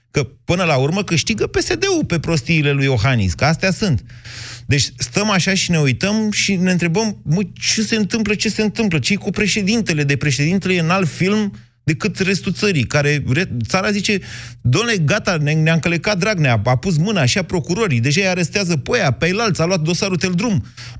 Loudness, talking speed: -17 LUFS, 190 wpm